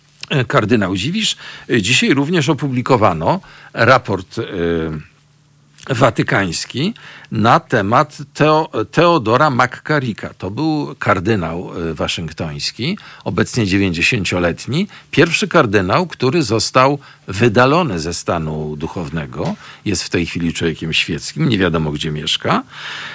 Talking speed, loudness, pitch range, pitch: 95 wpm, -16 LUFS, 90-145 Hz, 120 Hz